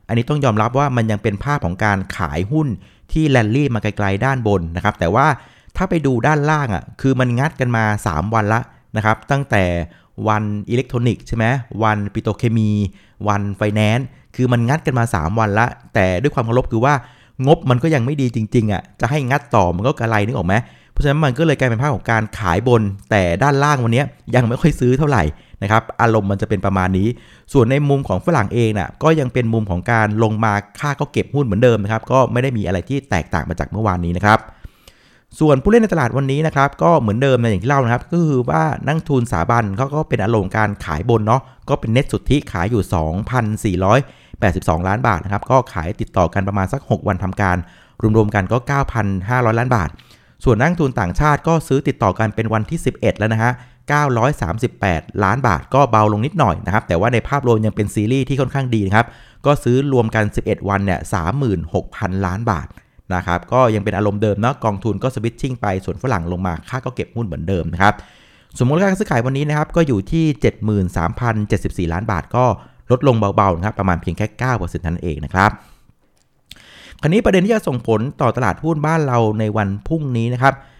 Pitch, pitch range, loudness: 115 Hz, 100-135 Hz, -17 LUFS